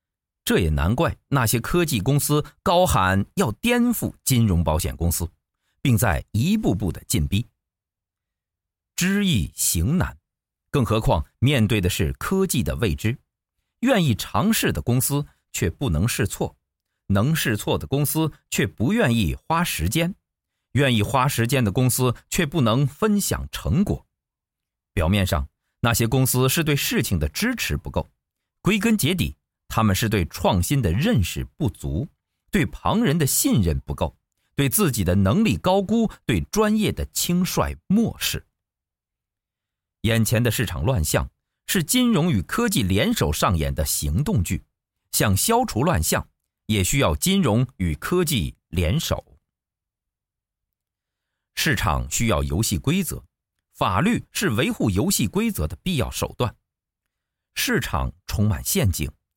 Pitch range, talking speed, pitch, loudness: 90-150 Hz, 205 characters per minute, 115 Hz, -22 LUFS